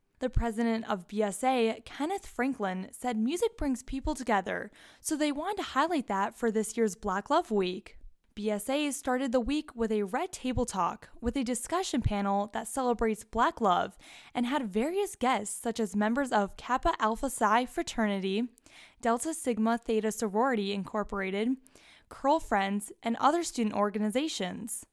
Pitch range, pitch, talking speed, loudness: 215-270 Hz, 235 Hz, 150 wpm, -31 LUFS